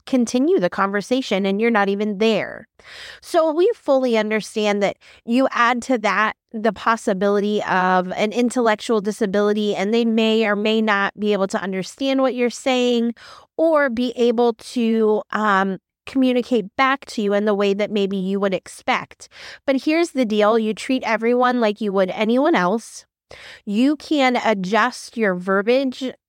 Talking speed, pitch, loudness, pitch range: 160 wpm, 225 Hz, -19 LUFS, 205-250 Hz